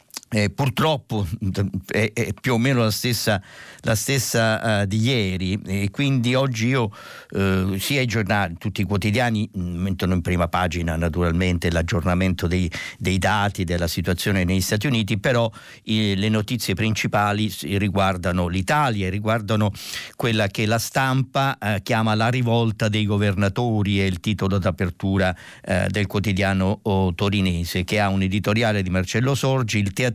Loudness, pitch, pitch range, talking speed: -22 LUFS, 105 Hz, 95-115 Hz, 150 wpm